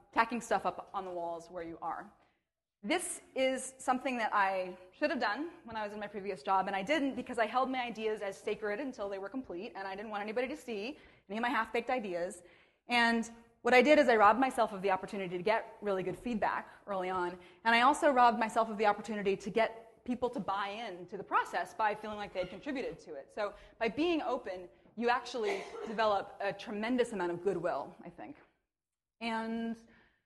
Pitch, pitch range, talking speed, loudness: 220 Hz, 195-245 Hz, 215 wpm, -33 LUFS